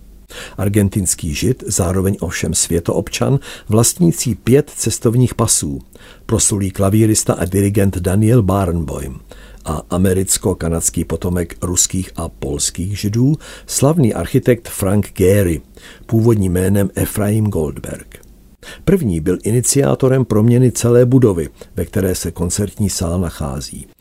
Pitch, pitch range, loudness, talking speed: 100 Hz, 90-115 Hz, -16 LUFS, 105 wpm